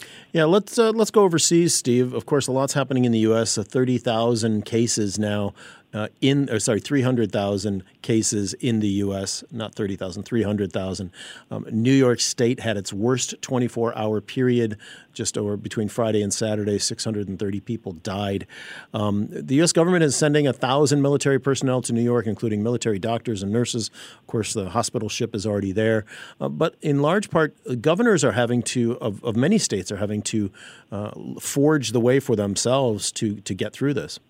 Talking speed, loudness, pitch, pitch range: 180 wpm, -22 LUFS, 115 Hz, 105-130 Hz